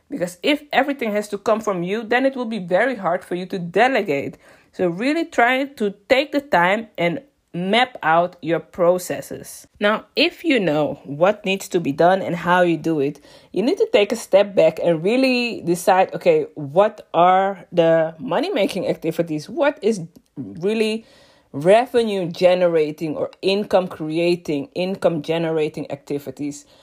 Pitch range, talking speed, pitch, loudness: 165-230 Hz, 160 wpm, 185 Hz, -20 LUFS